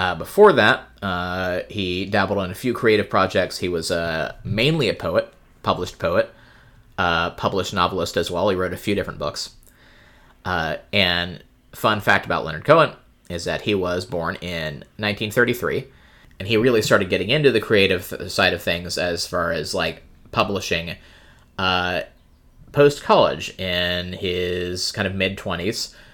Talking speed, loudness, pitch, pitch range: 160 wpm, -21 LUFS, 90 Hz, 90-105 Hz